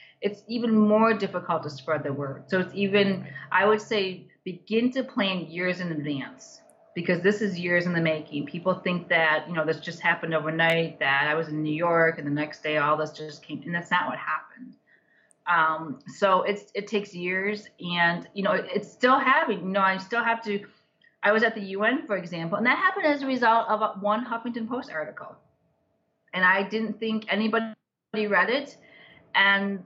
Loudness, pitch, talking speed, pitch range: -25 LUFS, 195 Hz, 205 wpm, 170-215 Hz